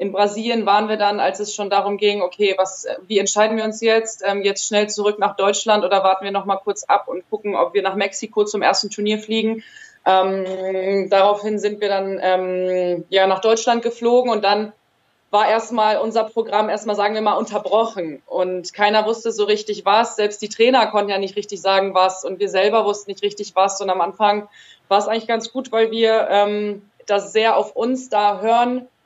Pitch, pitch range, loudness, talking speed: 205 Hz, 195-220 Hz, -19 LUFS, 205 wpm